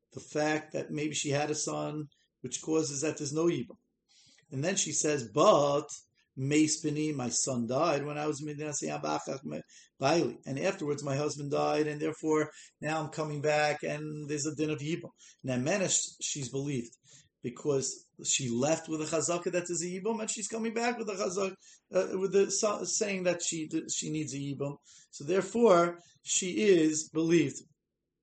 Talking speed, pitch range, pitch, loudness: 170 wpm, 145-170 Hz, 155 Hz, -31 LUFS